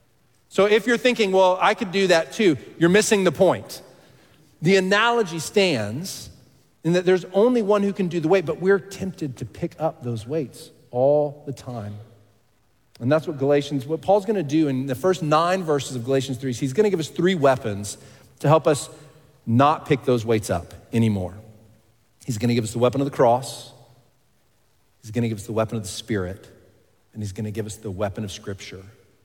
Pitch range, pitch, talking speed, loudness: 115-170 Hz, 135 Hz, 205 wpm, -22 LUFS